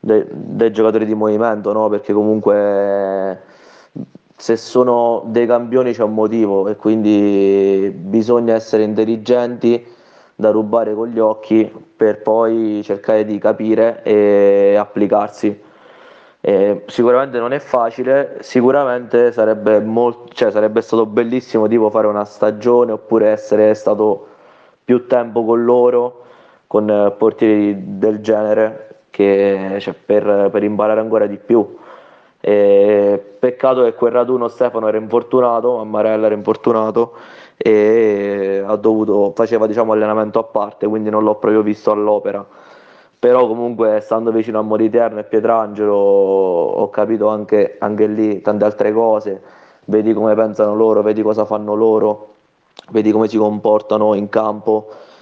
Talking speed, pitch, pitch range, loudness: 135 wpm, 110 Hz, 105-115 Hz, -15 LUFS